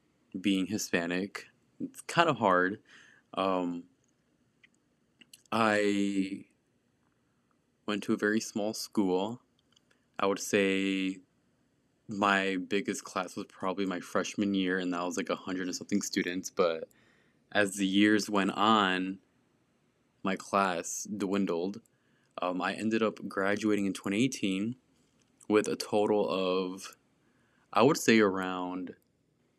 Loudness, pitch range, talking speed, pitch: -30 LUFS, 95-105 Hz, 120 wpm, 100 Hz